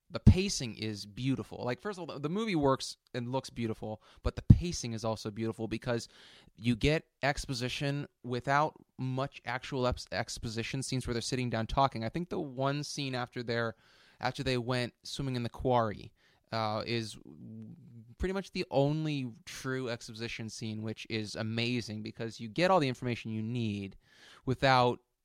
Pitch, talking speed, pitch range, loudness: 125 Hz, 165 wpm, 115-135 Hz, -33 LUFS